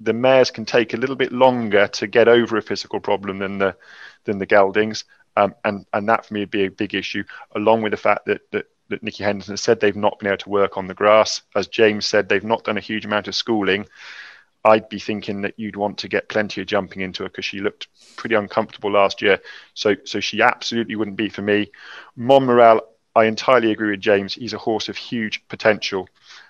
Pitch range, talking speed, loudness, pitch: 100-110 Hz, 225 wpm, -19 LUFS, 105 Hz